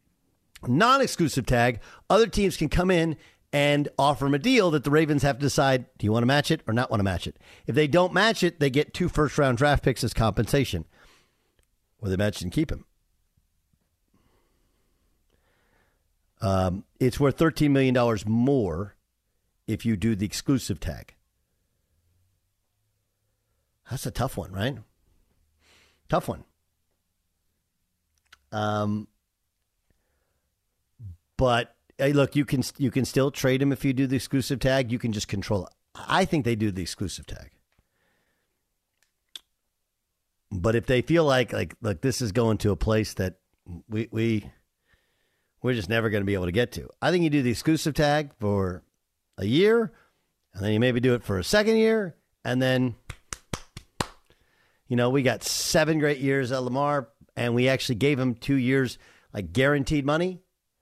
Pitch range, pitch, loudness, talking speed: 95-140 Hz, 115 Hz, -25 LUFS, 165 wpm